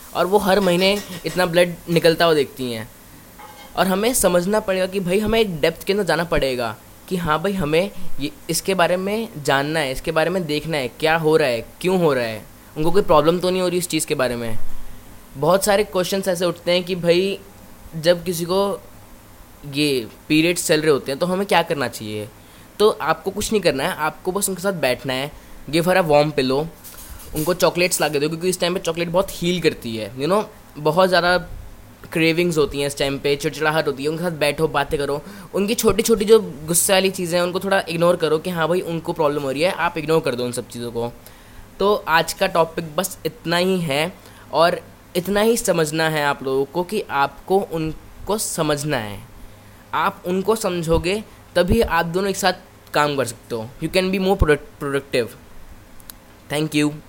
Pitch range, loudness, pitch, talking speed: 145-185 Hz, -20 LUFS, 165 Hz, 210 wpm